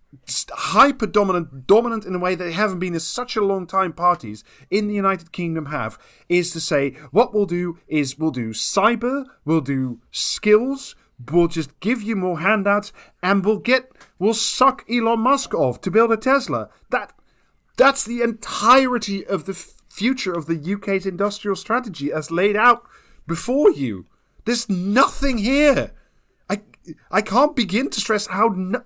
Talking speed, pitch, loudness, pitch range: 165 wpm, 200 Hz, -20 LUFS, 175-235 Hz